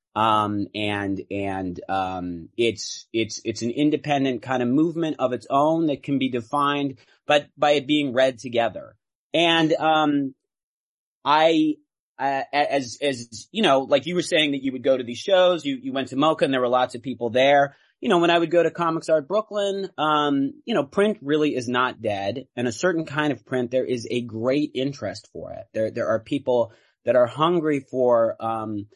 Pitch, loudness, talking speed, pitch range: 135 Hz, -23 LUFS, 200 wpm, 120-155 Hz